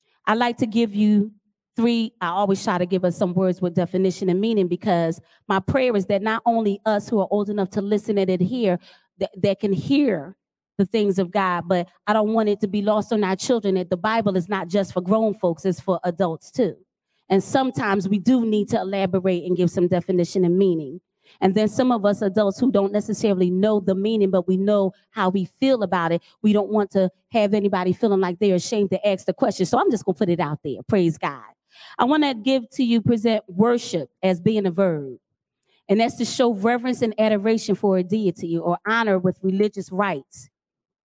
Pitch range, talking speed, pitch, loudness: 185-215 Hz, 220 wpm, 200 Hz, -21 LUFS